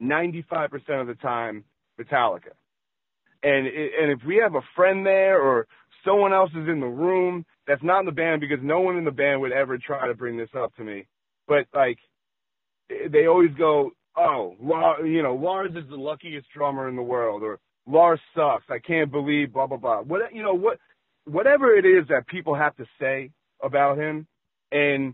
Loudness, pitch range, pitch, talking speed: -23 LUFS, 135-185 Hz, 155 Hz, 200 wpm